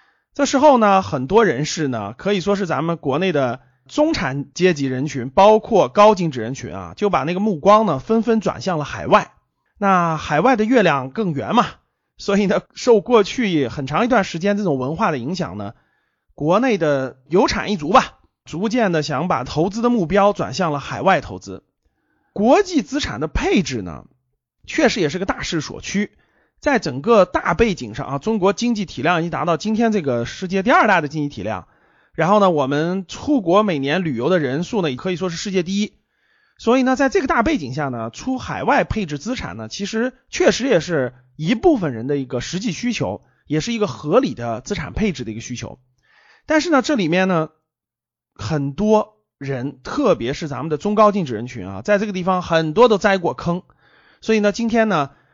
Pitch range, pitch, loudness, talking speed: 140-215 Hz, 185 Hz, -19 LUFS, 285 characters per minute